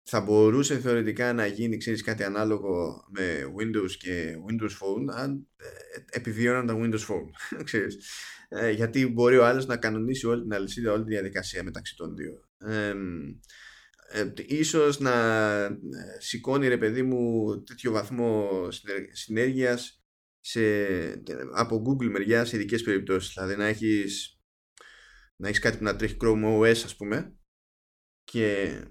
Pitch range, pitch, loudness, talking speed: 100-120 Hz, 110 Hz, -27 LUFS, 135 wpm